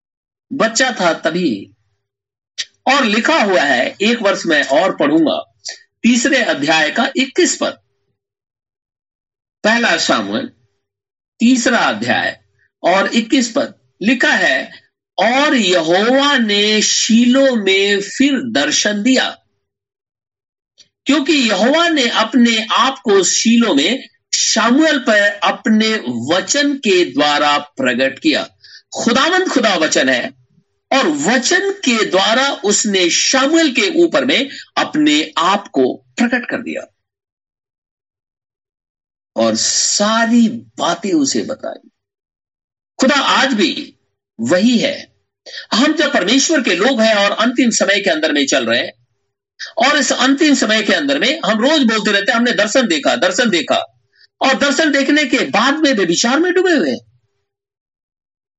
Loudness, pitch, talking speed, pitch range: -13 LUFS, 250 Hz, 125 wpm, 195-290 Hz